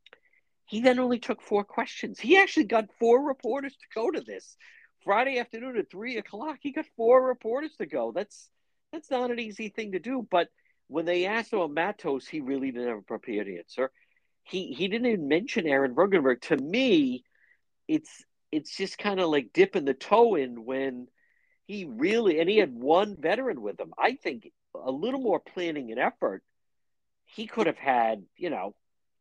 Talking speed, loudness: 190 wpm, -28 LUFS